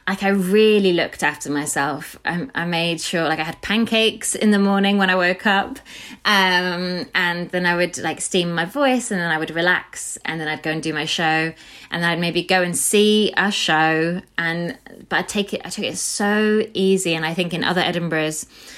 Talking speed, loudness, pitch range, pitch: 215 wpm, -19 LUFS, 160-200 Hz, 180 Hz